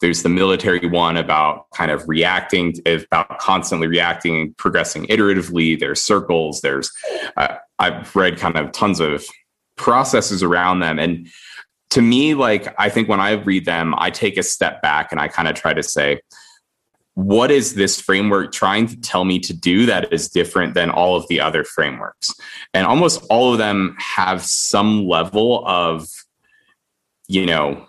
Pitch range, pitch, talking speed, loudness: 85-100 Hz, 90 Hz, 170 wpm, -17 LUFS